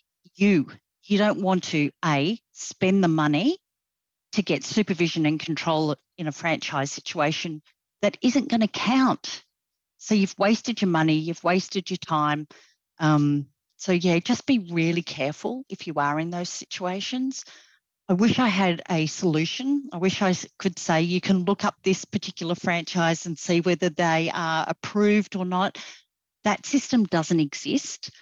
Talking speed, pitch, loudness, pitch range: 160 wpm, 180 Hz, -24 LUFS, 160-205 Hz